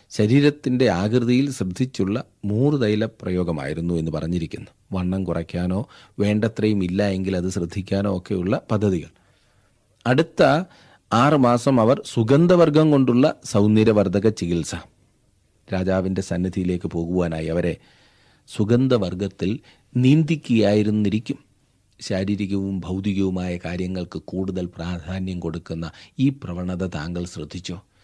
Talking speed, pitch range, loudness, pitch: 85 wpm, 90-120 Hz, -21 LUFS, 100 Hz